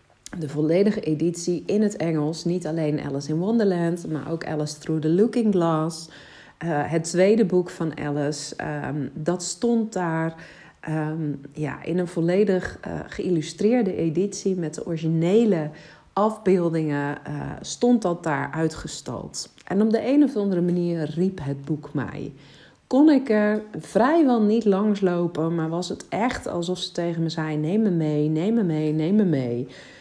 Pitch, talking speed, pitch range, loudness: 165 Hz, 160 wpm, 155-195 Hz, -24 LUFS